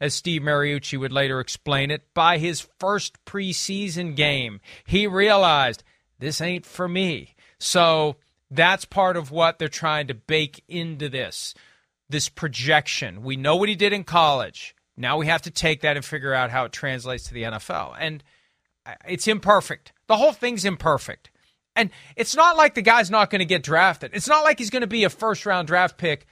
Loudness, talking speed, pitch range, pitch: -21 LUFS, 190 wpm, 145-195 Hz, 165 Hz